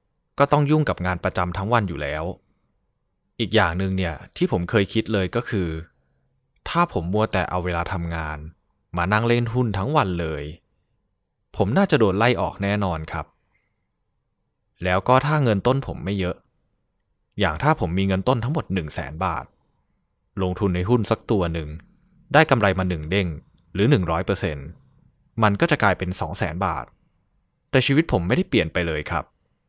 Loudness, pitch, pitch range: -22 LUFS, 95 Hz, 90-120 Hz